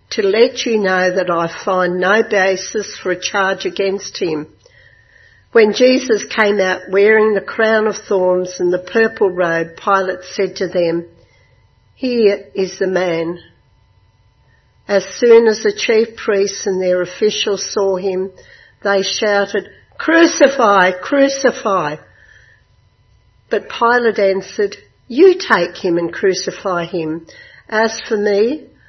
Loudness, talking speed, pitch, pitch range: -15 LUFS, 130 wpm, 195 Hz, 180-220 Hz